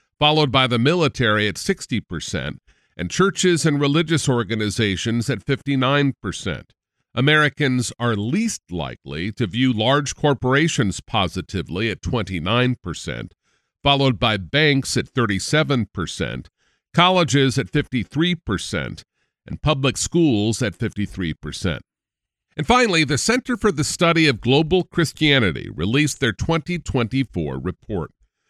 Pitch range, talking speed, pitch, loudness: 105-150 Hz, 105 wpm, 130 Hz, -20 LUFS